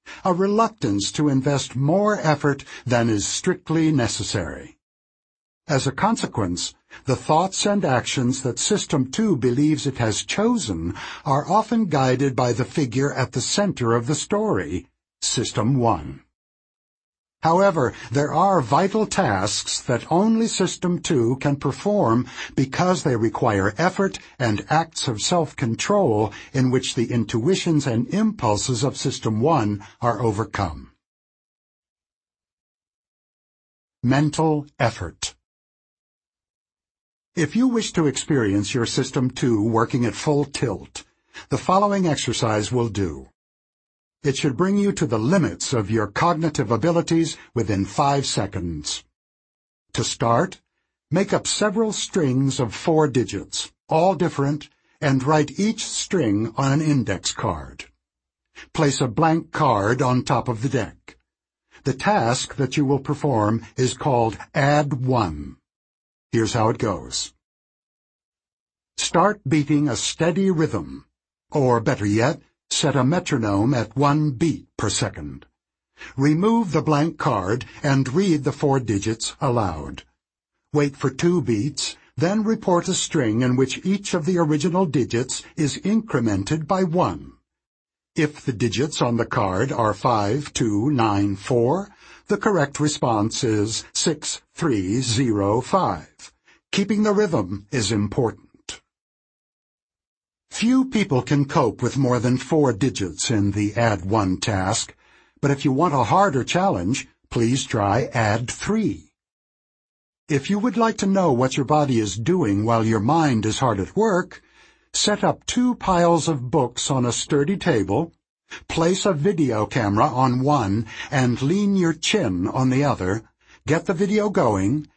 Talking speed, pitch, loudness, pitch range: 135 wpm, 135 Hz, -21 LUFS, 115-165 Hz